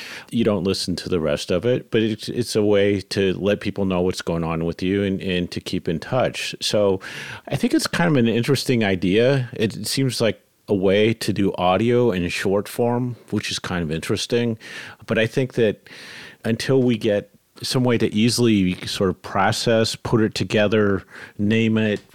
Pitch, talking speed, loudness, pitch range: 110 Hz, 200 wpm, -21 LUFS, 95-120 Hz